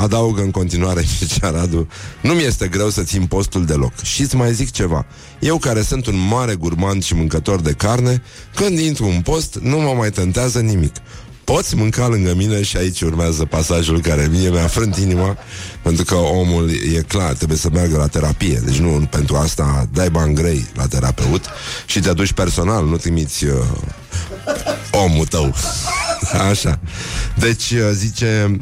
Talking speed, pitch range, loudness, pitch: 165 wpm, 80-110 Hz, -17 LUFS, 95 Hz